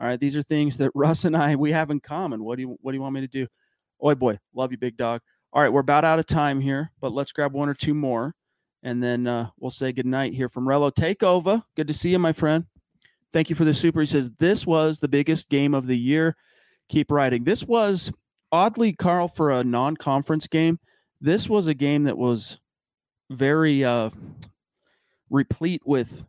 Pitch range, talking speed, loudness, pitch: 130-160 Hz, 220 wpm, -23 LUFS, 145 Hz